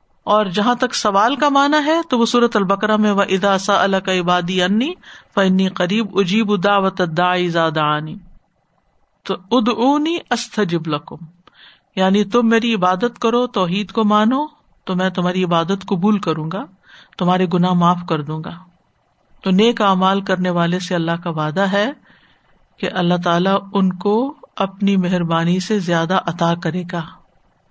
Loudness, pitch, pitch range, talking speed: -17 LUFS, 190 Hz, 180-215 Hz, 155 wpm